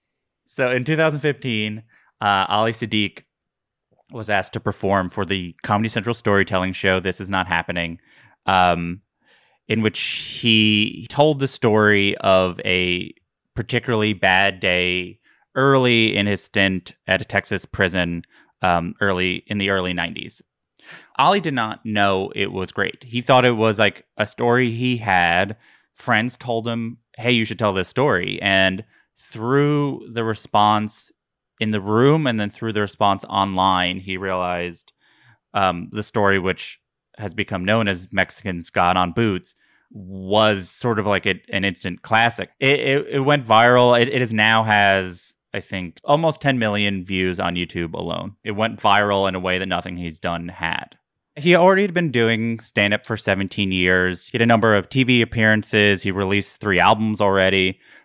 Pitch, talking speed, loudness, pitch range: 105 Hz, 160 wpm, -19 LUFS, 95-115 Hz